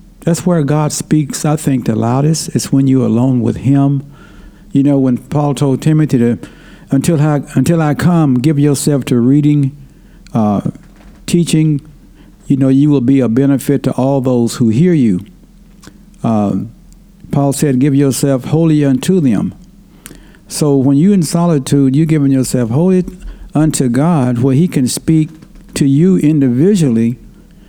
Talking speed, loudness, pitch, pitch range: 155 wpm, -12 LUFS, 145 Hz, 135-165 Hz